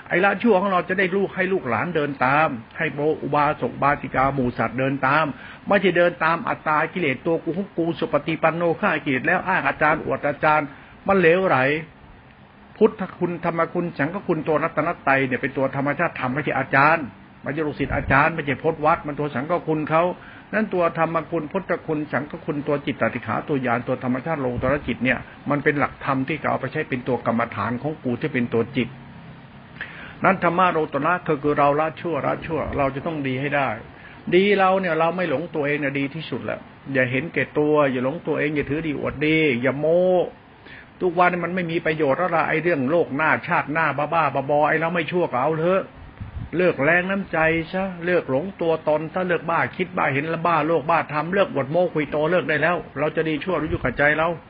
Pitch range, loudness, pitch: 140-170 Hz, -22 LUFS, 155 Hz